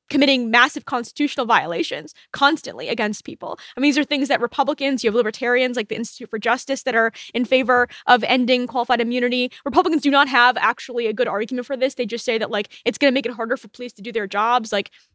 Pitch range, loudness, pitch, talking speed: 235-275 Hz, -20 LUFS, 245 Hz, 230 wpm